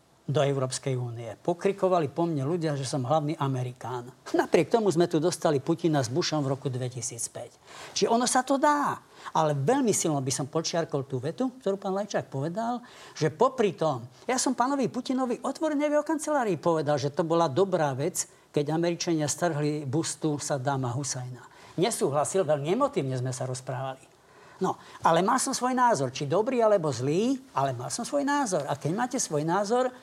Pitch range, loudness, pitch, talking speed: 140-220 Hz, -27 LUFS, 165 Hz, 175 wpm